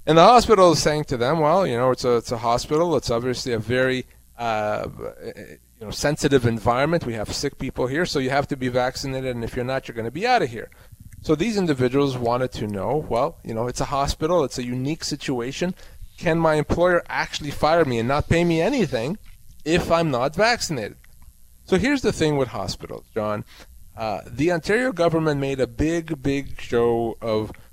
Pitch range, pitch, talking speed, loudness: 120-160 Hz, 135 Hz, 205 wpm, -22 LUFS